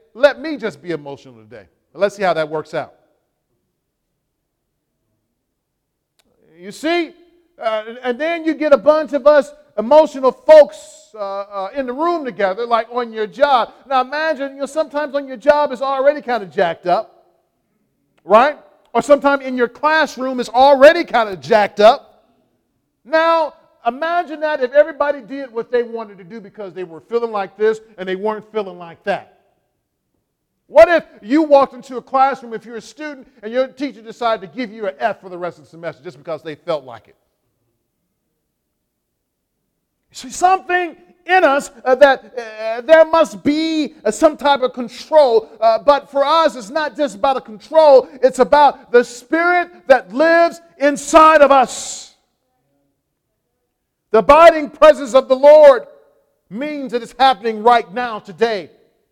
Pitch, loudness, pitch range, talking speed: 260 Hz, -15 LUFS, 215-300 Hz, 165 wpm